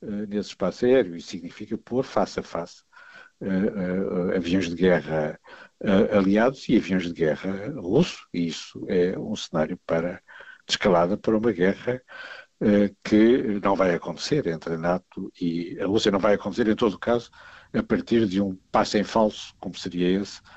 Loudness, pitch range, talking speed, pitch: -24 LUFS, 90-110 Hz, 160 wpm, 100 Hz